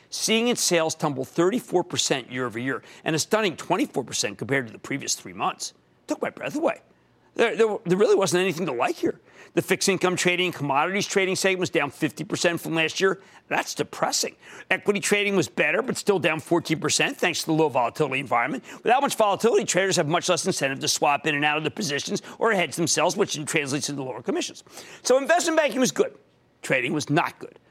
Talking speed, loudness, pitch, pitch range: 205 wpm, -24 LUFS, 175 Hz, 155-200 Hz